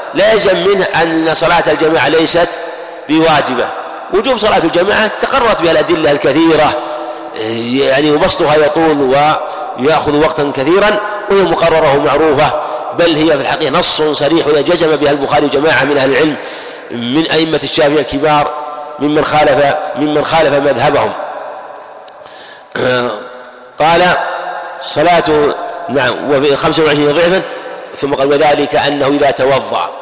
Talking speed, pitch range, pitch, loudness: 115 wpm, 145-170 Hz, 150 Hz, -11 LUFS